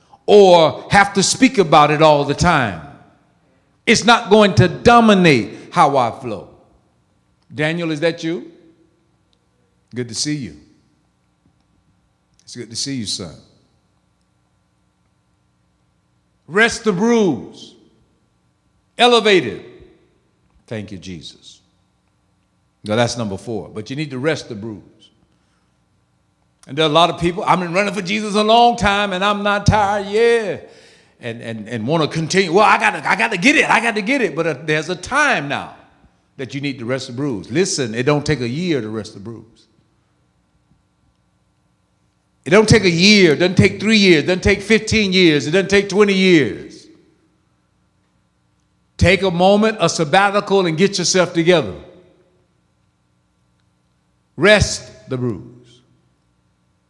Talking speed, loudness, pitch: 150 wpm, -15 LUFS, 155 Hz